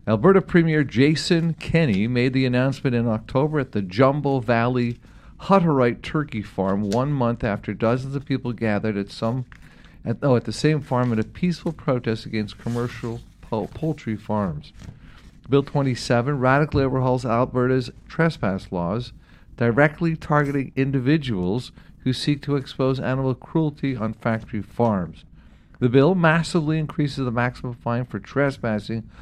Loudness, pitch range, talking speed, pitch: -22 LUFS, 115-145 Hz, 140 wpm, 125 Hz